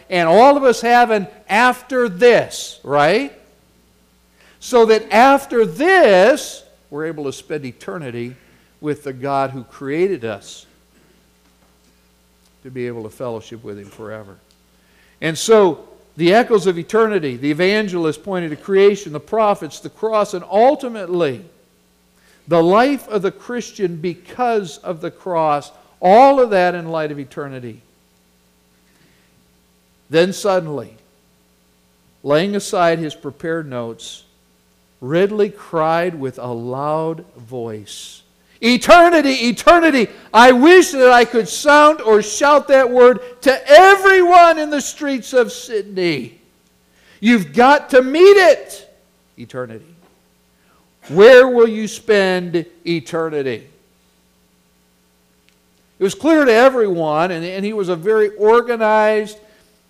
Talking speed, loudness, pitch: 120 wpm, -14 LUFS, 170 Hz